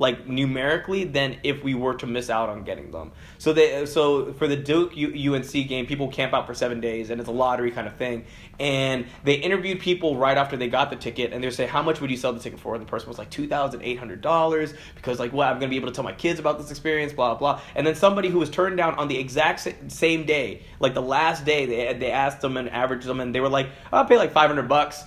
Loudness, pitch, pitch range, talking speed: -24 LUFS, 140 Hz, 125-155 Hz, 260 wpm